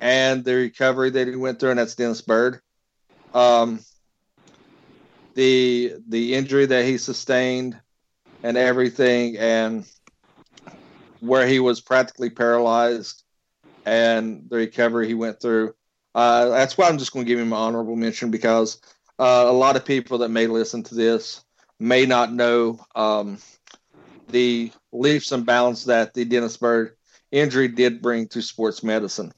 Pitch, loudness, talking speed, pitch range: 120 Hz, -20 LUFS, 150 wpm, 115-125 Hz